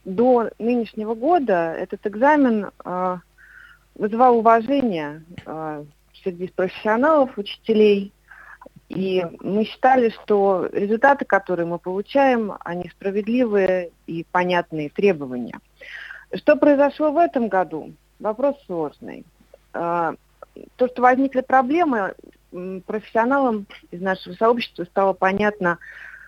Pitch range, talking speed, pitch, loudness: 180-250 Hz, 90 wpm, 210 Hz, -20 LUFS